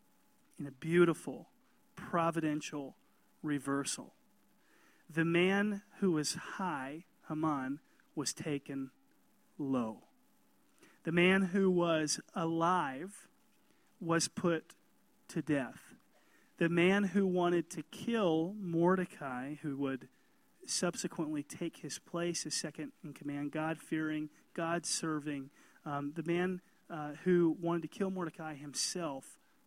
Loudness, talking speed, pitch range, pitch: -35 LUFS, 110 wpm, 150-180 Hz, 165 Hz